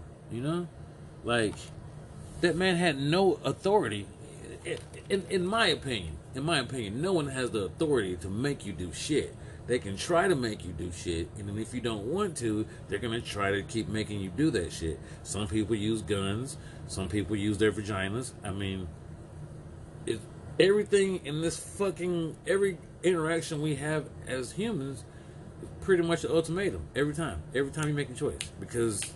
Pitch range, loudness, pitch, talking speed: 105-165 Hz, -31 LUFS, 125 Hz, 180 wpm